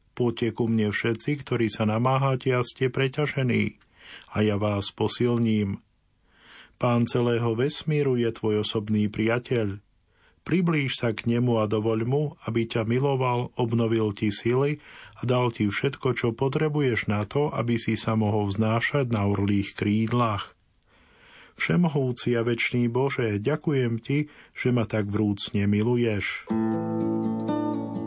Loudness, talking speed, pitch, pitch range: -25 LUFS, 130 wpm, 115 Hz, 110-130 Hz